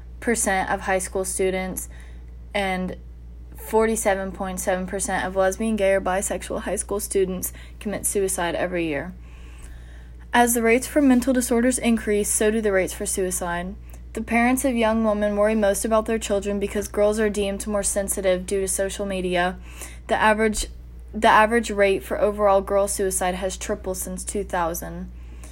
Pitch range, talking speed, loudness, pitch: 180-215 Hz, 155 wpm, -22 LUFS, 195 Hz